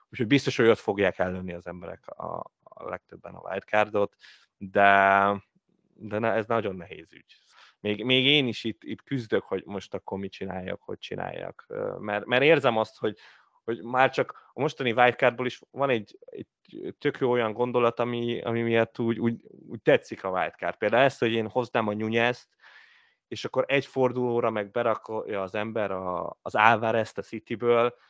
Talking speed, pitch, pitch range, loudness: 175 wpm, 115 Hz, 105-125 Hz, -26 LUFS